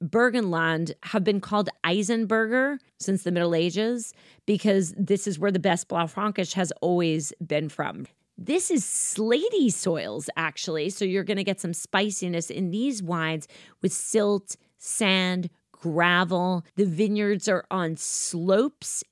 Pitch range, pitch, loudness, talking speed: 170-210 Hz, 190 Hz, -25 LUFS, 140 wpm